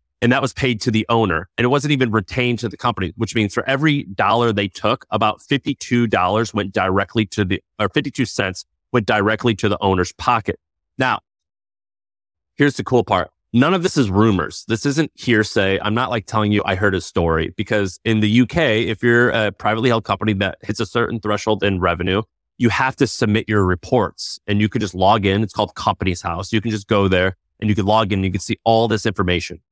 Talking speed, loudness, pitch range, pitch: 220 wpm, -19 LUFS, 95-120 Hz, 110 Hz